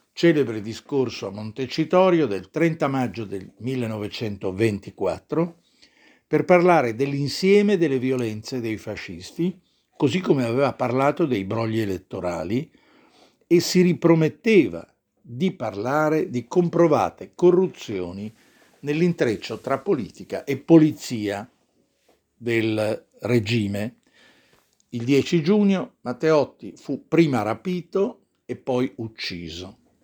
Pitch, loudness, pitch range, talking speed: 130 Hz, -22 LUFS, 110-170 Hz, 95 wpm